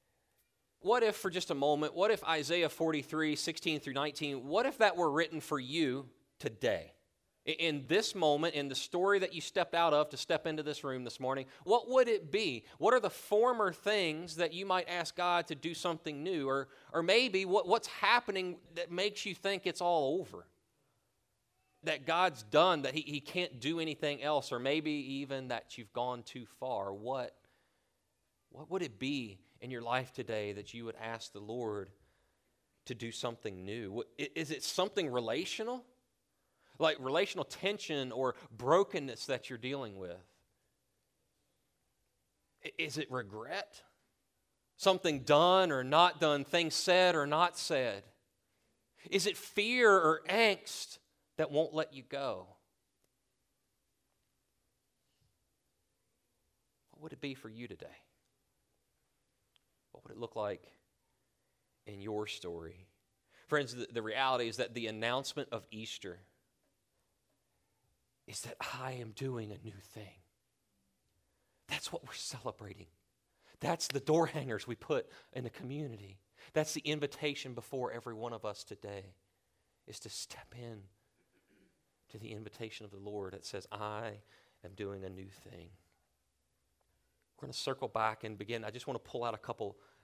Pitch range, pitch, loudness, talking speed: 110-165 Hz, 135 Hz, -35 LUFS, 155 wpm